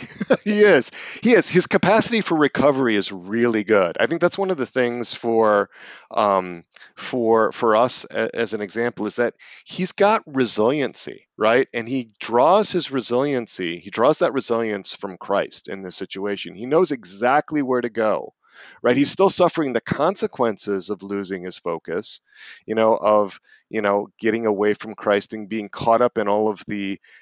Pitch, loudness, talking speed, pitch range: 115 Hz, -20 LUFS, 175 wpm, 105-150 Hz